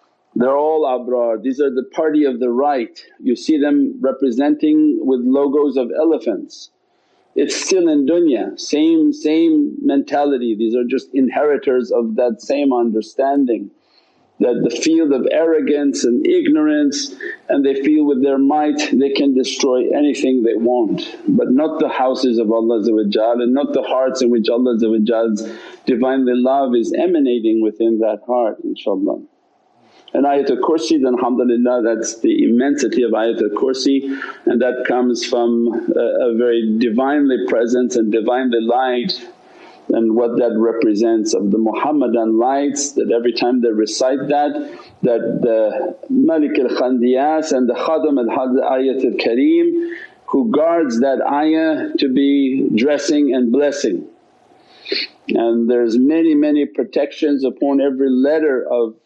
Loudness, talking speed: -16 LUFS, 140 wpm